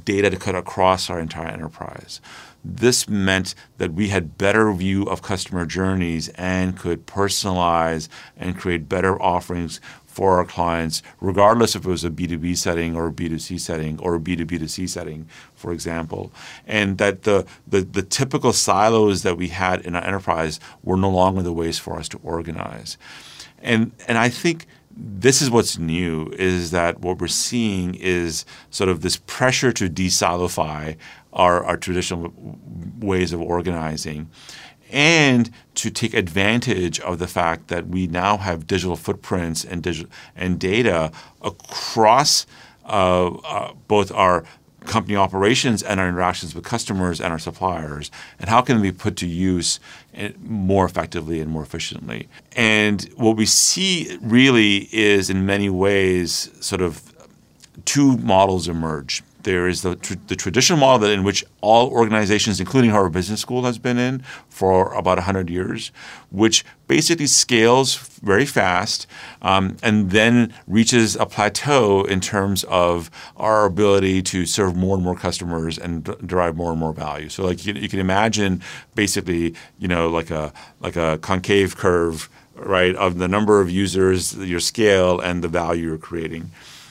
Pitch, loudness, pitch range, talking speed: 95 Hz, -19 LUFS, 85-105 Hz, 160 wpm